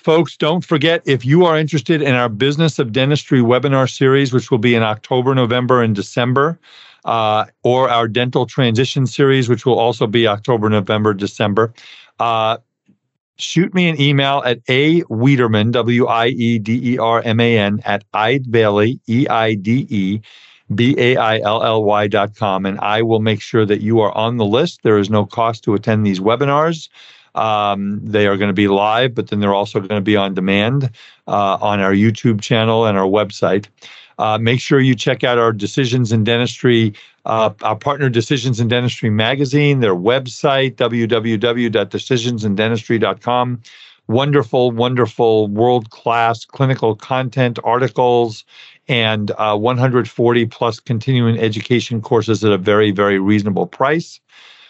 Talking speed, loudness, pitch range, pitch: 145 wpm, -15 LUFS, 110-130 Hz, 115 Hz